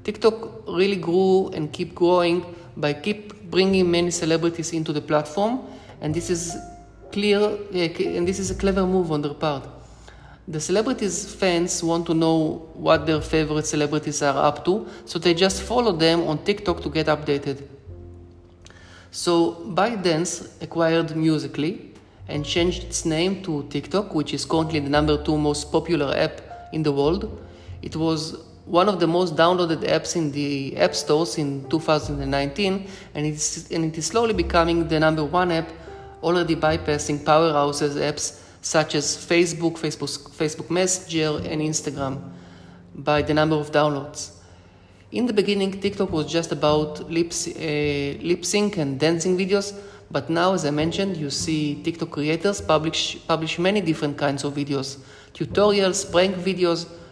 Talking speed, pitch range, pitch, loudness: 155 wpm, 150-180 Hz, 160 Hz, -23 LUFS